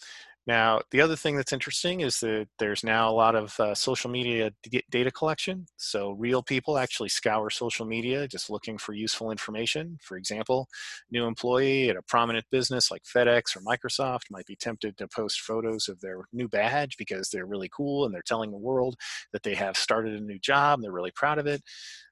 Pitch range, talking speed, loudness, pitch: 110-135 Hz, 205 wpm, -28 LUFS, 120 Hz